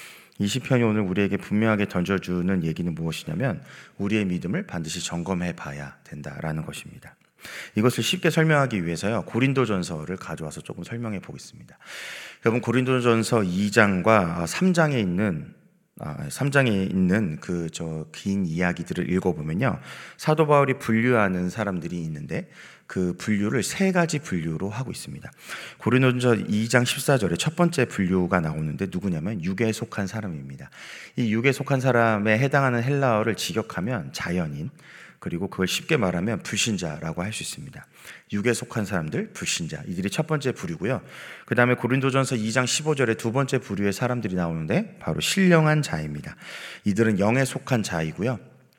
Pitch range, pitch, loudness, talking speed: 90-130 Hz, 110 Hz, -24 LUFS, 350 characters per minute